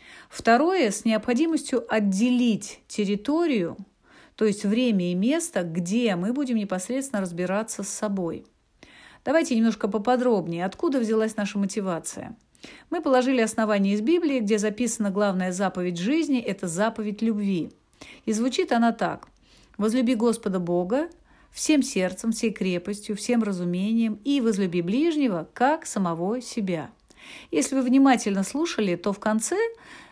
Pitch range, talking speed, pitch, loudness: 195-255 Hz, 125 wpm, 220 Hz, -25 LUFS